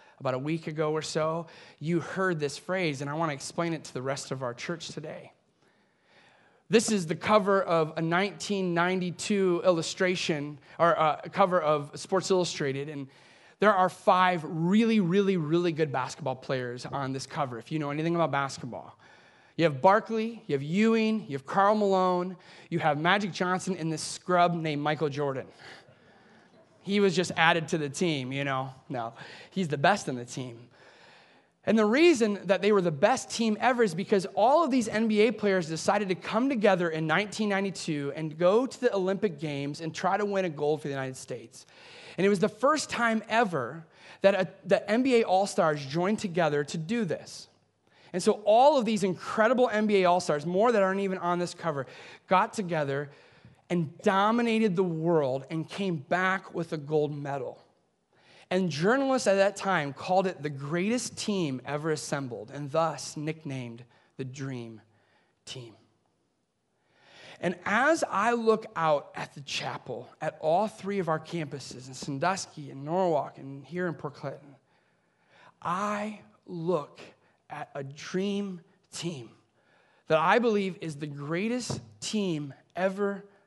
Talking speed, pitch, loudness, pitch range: 165 wpm, 175 Hz, -28 LUFS, 150-200 Hz